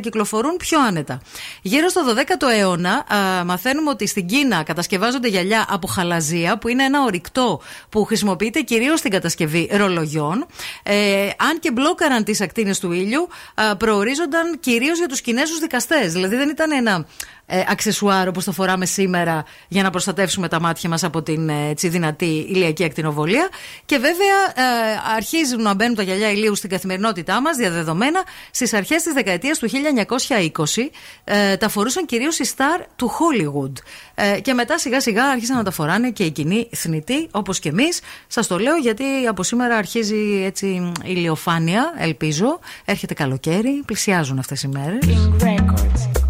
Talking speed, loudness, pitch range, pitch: 155 wpm, -19 LUFS, 180-260 Hz, 210 Hz